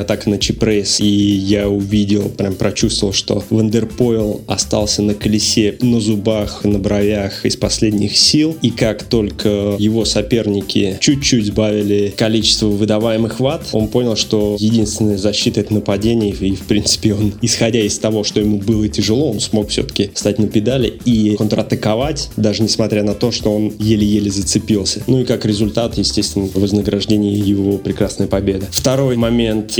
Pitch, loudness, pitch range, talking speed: 105 Hz, -15 LUFS, 105-110 Hz, 155 wpm